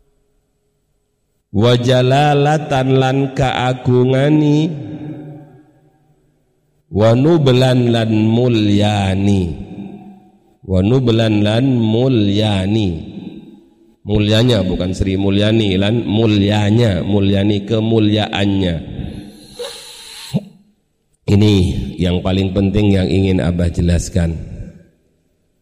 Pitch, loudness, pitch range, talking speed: 110 Hz, -14 LUFS, 100-140 Hz, 65 wpm